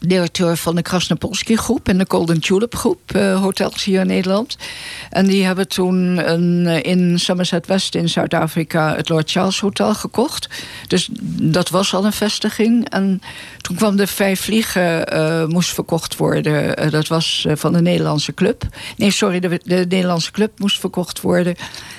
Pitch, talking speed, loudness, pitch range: 185 Hz, 170 wpm, -17 LUFS, 170-195 Hz